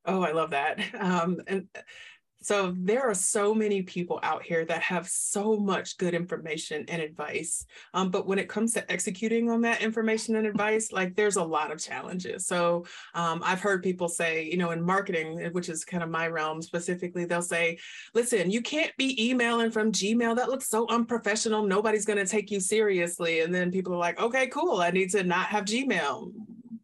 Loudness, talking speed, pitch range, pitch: -28 LUFS, 200 wpm, 170-220 Hz, 195 Hz